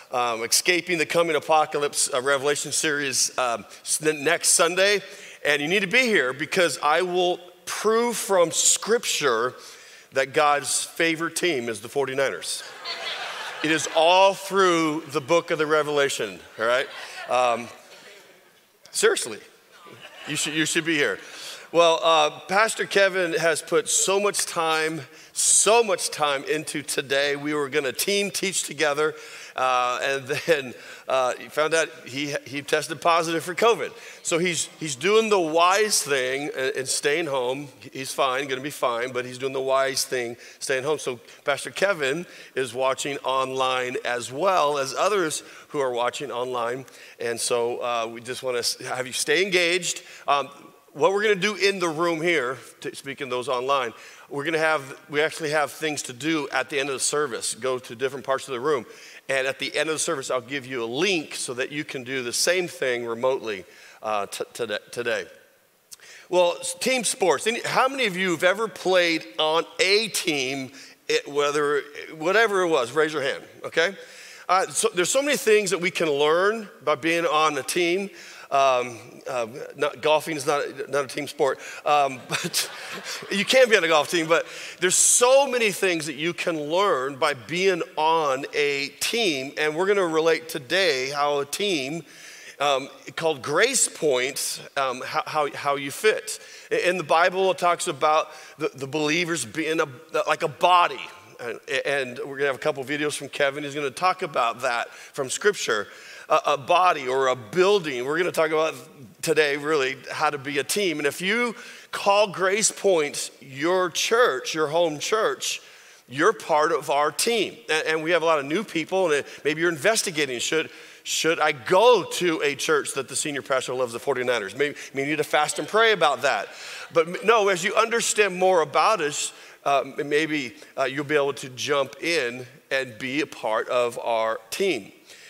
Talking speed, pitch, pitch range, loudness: 180 wpm, 160 Hz, 140-190 Hz, -23 LUFS